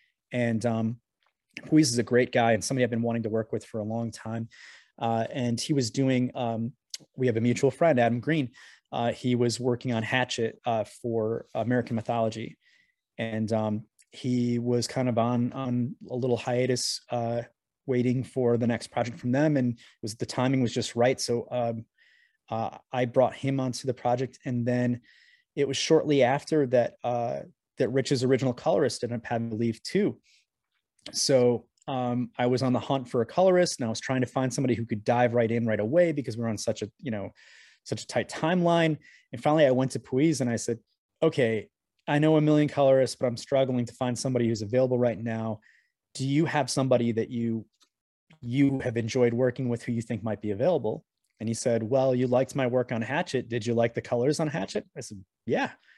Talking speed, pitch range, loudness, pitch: 205 wpm, 115-135 Hz, -27 LUFS, 125 Hz